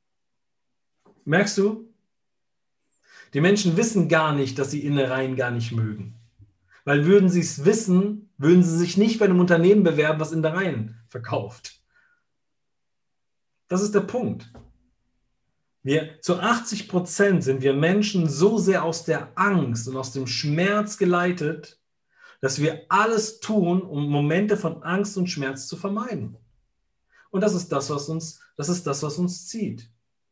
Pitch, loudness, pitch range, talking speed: 165 Hz, -23 LUFS, 140-200 Hz, 150 wpm